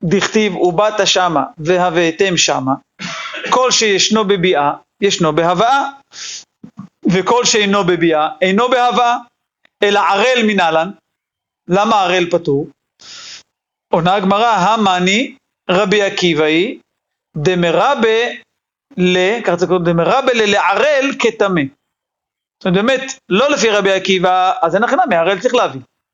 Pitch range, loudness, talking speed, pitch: 175-225 Hz, -14 LUFS, 100 wpm, 195 Hz